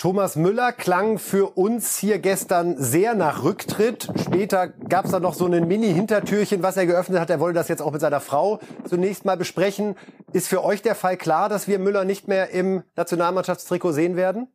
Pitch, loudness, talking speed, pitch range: 185 Hz, -22 LUFS, 200 wpm, 175-200 Hz